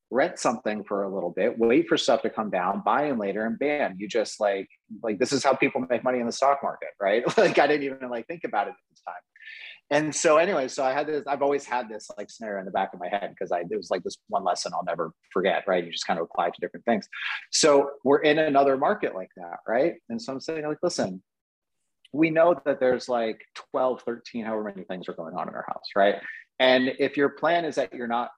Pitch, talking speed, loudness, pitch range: 135 Hz, 255 wpm, -25 LUFS, 120-145 Hz